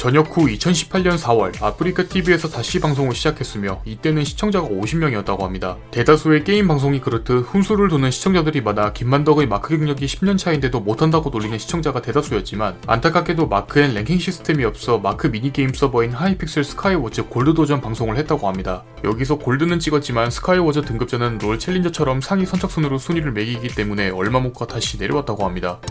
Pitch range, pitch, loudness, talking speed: 115-165 Hz, 140 Hz, -19 LUFS, 450 characters per minute